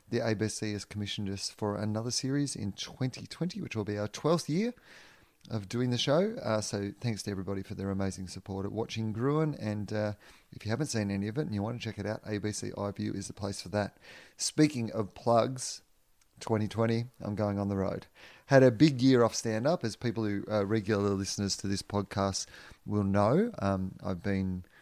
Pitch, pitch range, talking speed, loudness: 105 Hz, 100-120 Hz, 205 wpm, -32 LUFS